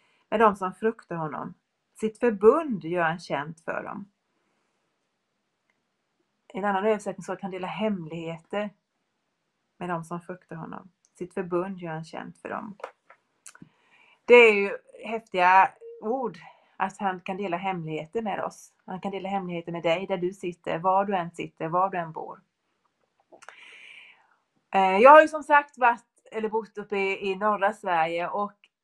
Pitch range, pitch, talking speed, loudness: 180-220 Hz, 195 Hz, 155 wpm, -25 LUFS